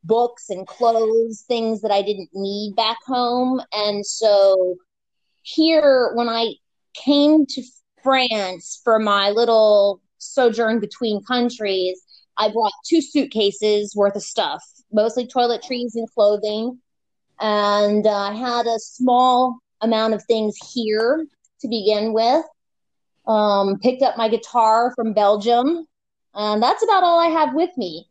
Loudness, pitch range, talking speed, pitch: -19 LUFS, 210-250 Hz, 135 wpm, 225 Hz